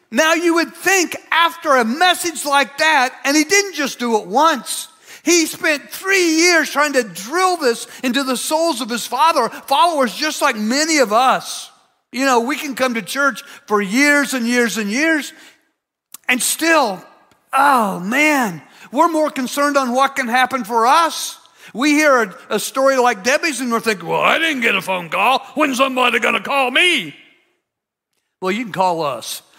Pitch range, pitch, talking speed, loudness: 245-320 Hz, 275 Hz, 180 wpm, -16 LUFS